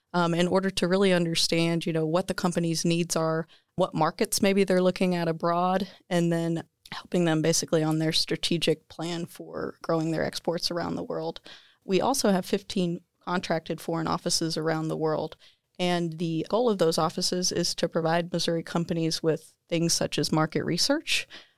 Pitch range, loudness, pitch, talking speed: 165-180 Hz, -27 LUFS, 170 Hz, 175 wpm